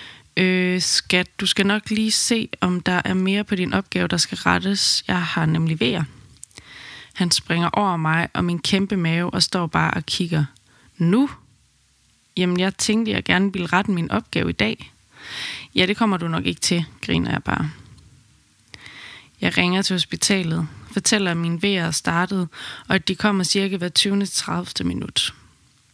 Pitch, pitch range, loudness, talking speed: 180 Hz, 170-195 Hz, -21 LUFS, 175 wpm